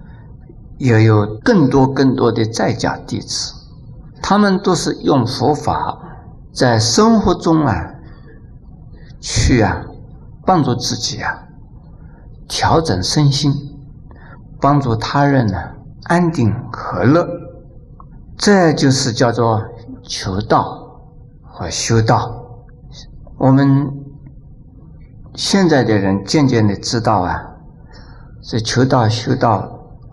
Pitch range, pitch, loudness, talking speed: 115-140 Hz, 130 Hz, -15 LUFS, 140 characters per minute